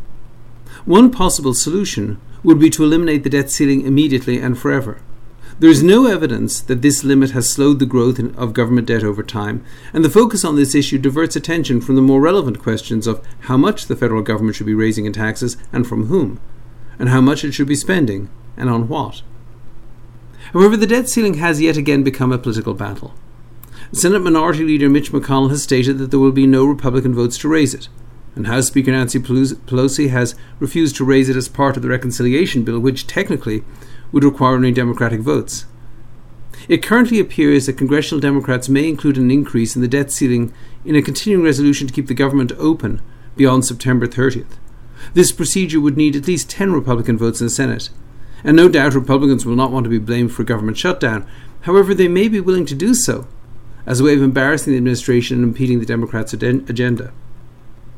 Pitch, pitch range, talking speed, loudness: 130 Hz, 120-145 Hz, 195 wpm, -15 LUFS